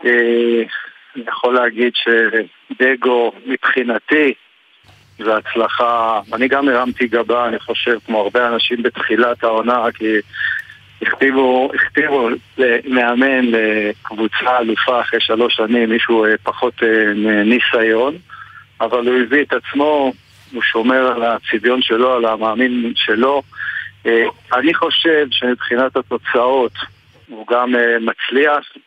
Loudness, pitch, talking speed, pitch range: -15 LUFS, 120 Hz, 105 wpm, 115-125 Hz